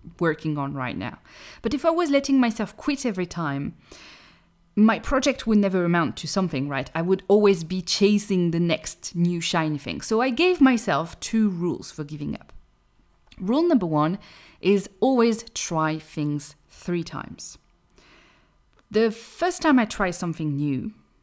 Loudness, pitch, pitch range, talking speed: -24 LUFS, 190 Hz, 160-230 Hz, 160 wpm